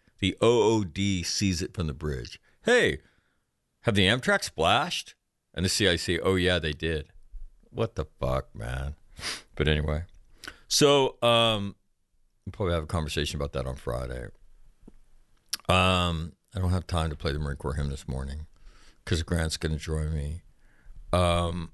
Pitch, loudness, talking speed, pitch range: 80 Hz, -27 LUFS, 150 wpm, 75-95 Hz